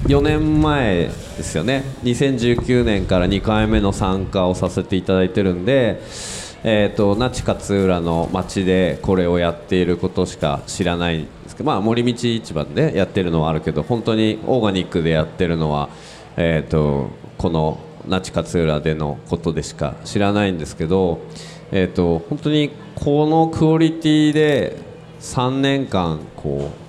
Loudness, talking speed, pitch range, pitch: -19 LUFS, 295 characters per minute, 85-125 Hz, 95 Hz